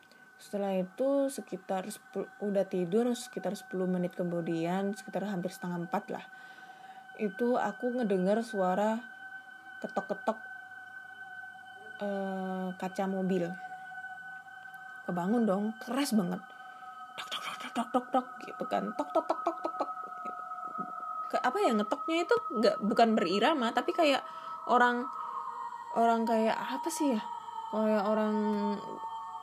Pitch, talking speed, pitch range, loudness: 245 Hz, 120 wpm, 195-325 Hz, -32 LUFS